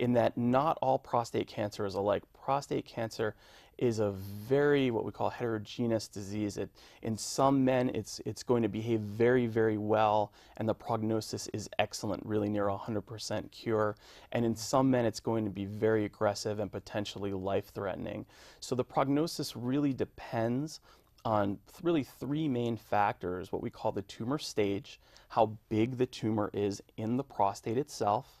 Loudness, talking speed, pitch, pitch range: -33 LUFS, 165 wpm, 110 Hz, 105-125 Hz